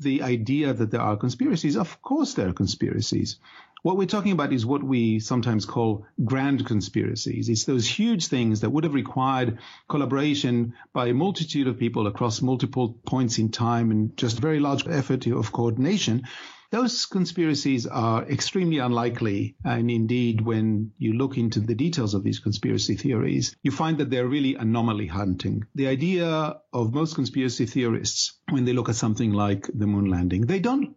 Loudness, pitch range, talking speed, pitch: -25 LUFS, 115-140 Hz, 170 wpm, 125 Hz